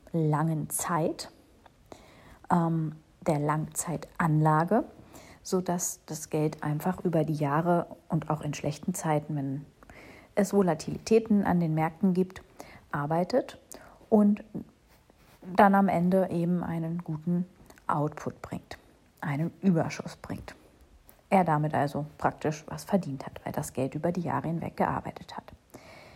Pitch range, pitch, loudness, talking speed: 150-185 Hz, 165 Hz, -29 LUFS, 125 wpm